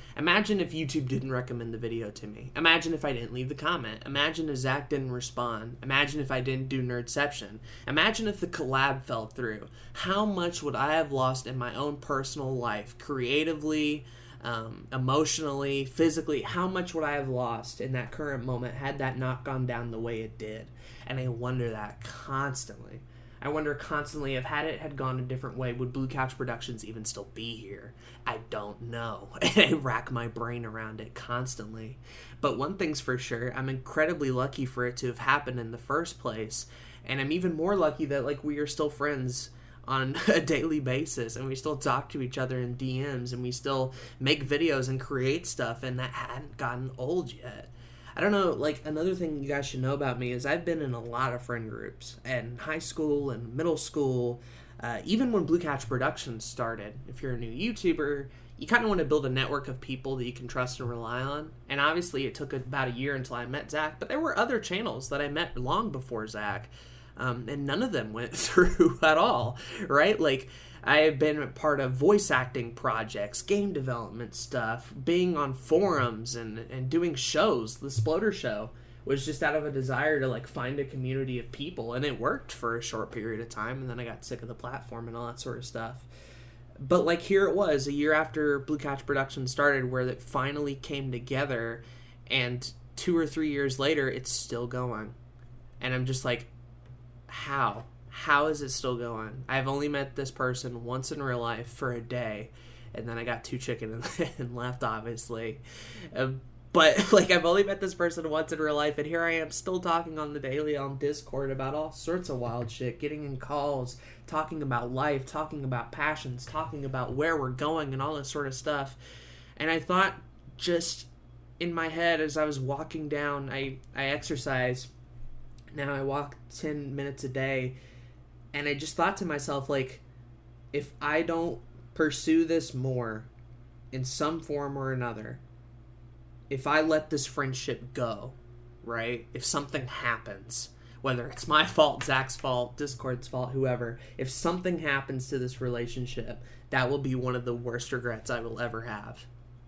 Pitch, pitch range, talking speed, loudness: 130 Hz, 120-145 Hz, 195 wpm, -30 LUFS